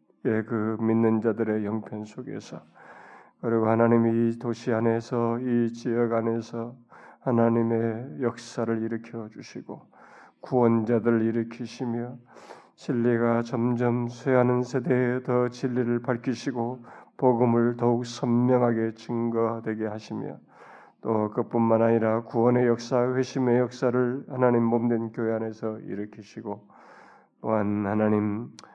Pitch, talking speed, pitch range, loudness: 115 Hz, 265 characters per minute, 115-120 Hz, -26 LUFS